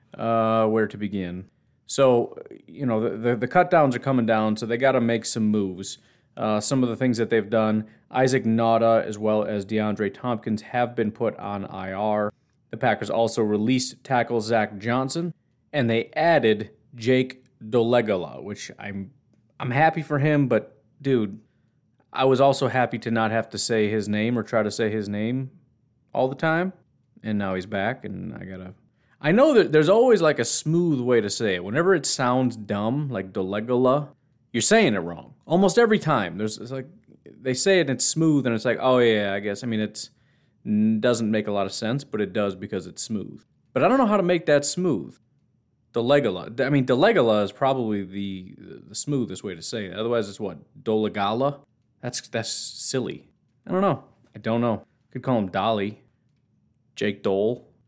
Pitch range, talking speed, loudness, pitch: 110-135 Hz, 195 wpm, -23 LUFS, 115 Hz